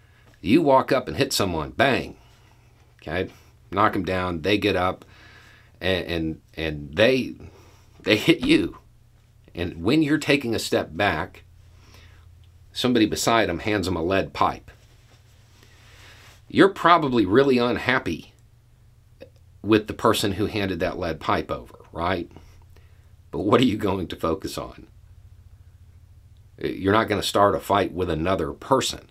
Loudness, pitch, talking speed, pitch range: -22 LUFS, 100 Hz, 140 wpm, 90-110 Hz